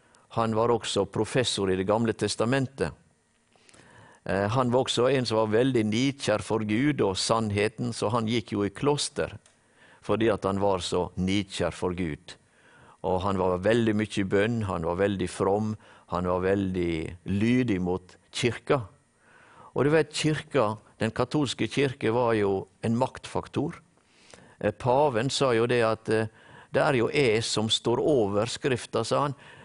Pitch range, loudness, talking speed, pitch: 100-120 Hz, -27 LUFS, 155 wpm, 110 Hz